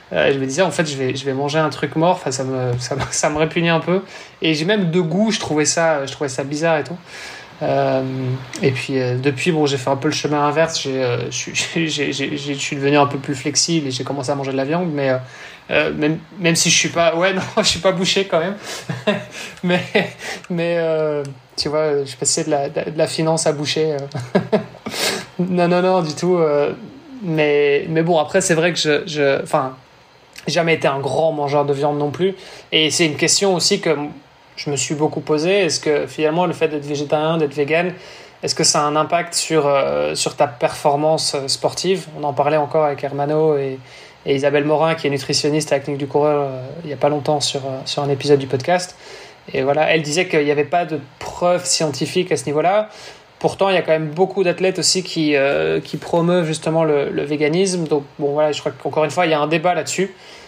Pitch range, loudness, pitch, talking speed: 145-170 Hz, -18 LUFS, 155 Hz, 230 wpm